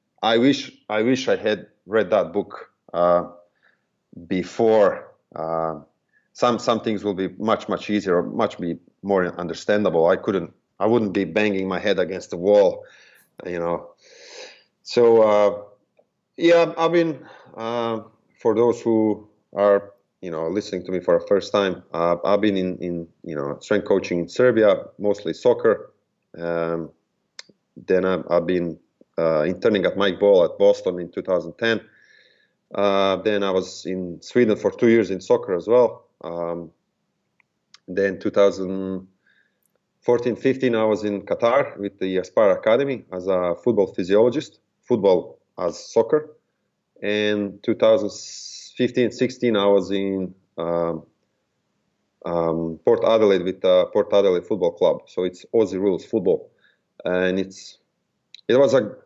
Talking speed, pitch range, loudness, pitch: 145 wpm, 90-120 Hz, -21 LUFS, 100 Hz